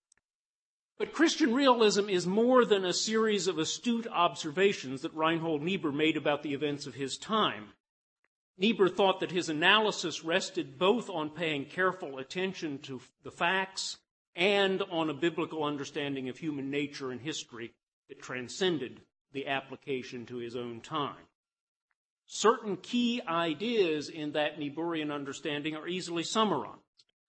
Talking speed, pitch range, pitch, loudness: 140 wpm, 145-195 Hz, 165 Hz, -31 LUFS